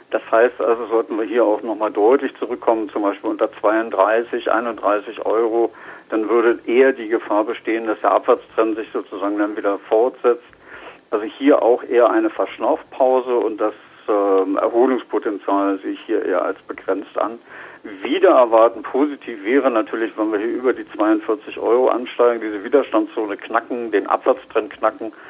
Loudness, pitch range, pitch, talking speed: -19 LUFS, 105-130 Hz, 115 Hz, 160 wpm